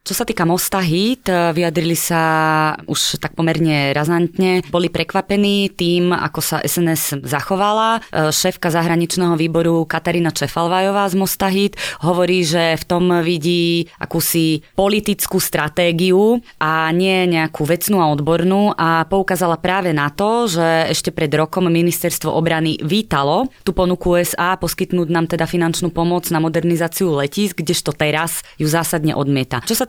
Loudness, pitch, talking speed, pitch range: -17 LUFS, 170 Hz, 135 wpm, 160-185 Hz